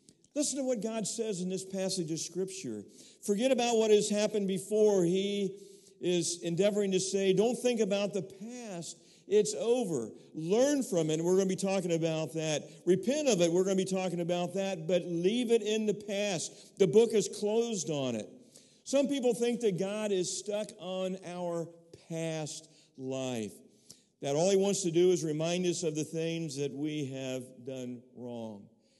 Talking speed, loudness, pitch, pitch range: 185 wpm, -31 LUFS, 190 Hz, 165-210 Hz